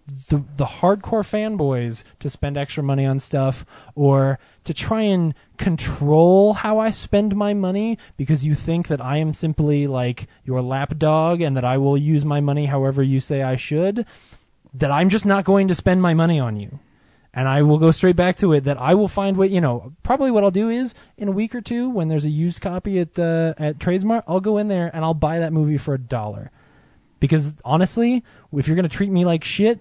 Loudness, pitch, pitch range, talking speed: -20 LUFS, 155 Hz, 140-190 Hz, 220 wpm